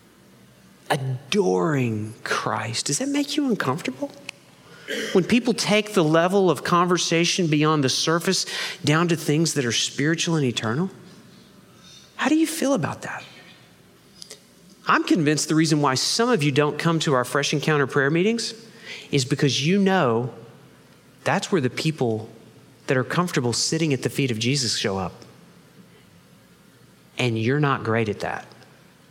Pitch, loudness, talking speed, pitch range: 155 Hz, -22 LUFS, 150 wpm, 130-190 Hz